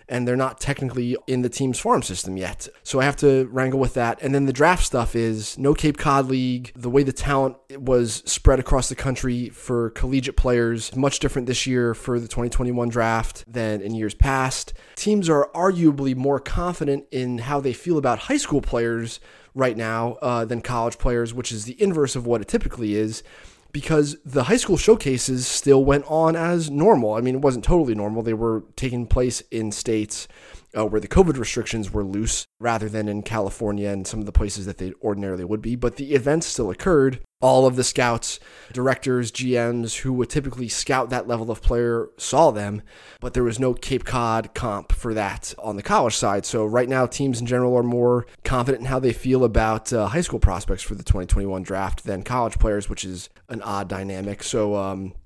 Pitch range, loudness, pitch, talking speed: 110-135 Hz, -22 LUFS, 120 Hz, 205 wpm